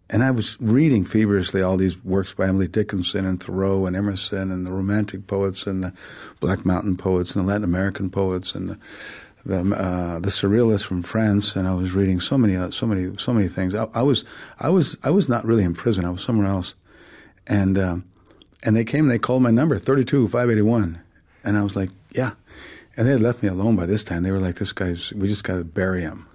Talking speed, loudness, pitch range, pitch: 235 wpm, -22 LUFS, 95-110 Hz, 95 Hz